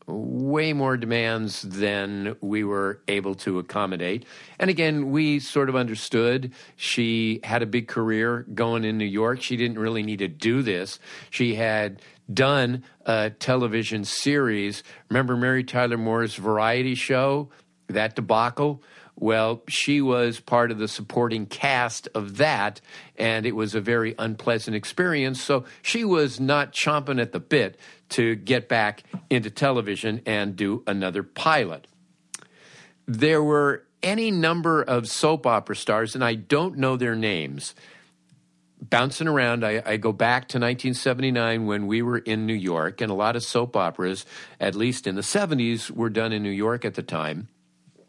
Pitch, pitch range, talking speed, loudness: 115 Hz, 110-130 Hz, 155 wpm, -24 LUFS